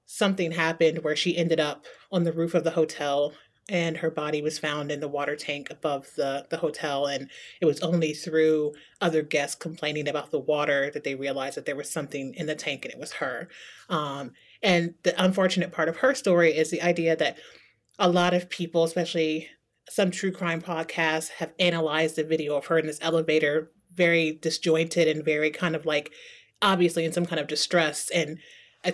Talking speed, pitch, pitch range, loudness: 195 wpm, 160 Hz, 150-175 Hz, -26 LUFS